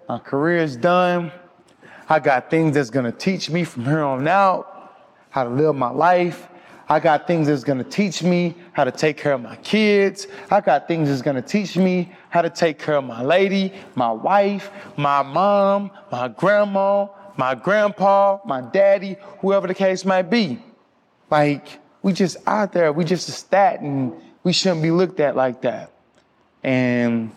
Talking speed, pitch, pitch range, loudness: 180 wpm, 175 Hz, 145-195 Hz, -19 LUFS